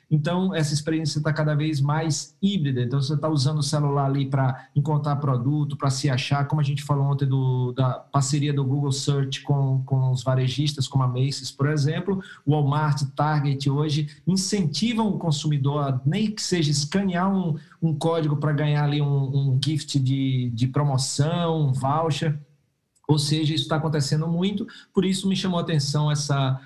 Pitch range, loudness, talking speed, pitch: 140-155 Hz, -24 LUFS, 180 wpm, 145 Hz